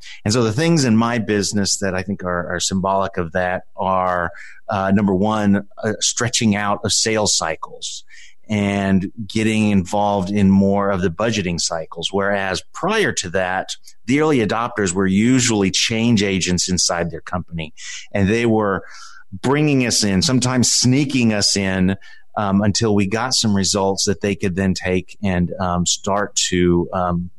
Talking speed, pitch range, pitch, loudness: 160 wpm, 95-110 Hz, 100 Hz, -18 LUFS